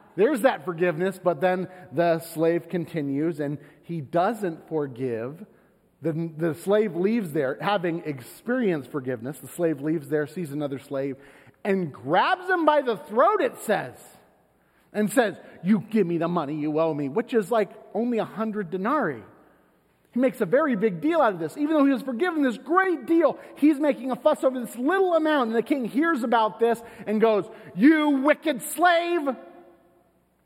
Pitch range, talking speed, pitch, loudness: 165-260 Hz, 175 wpm, 205 Hz, -25 LUFS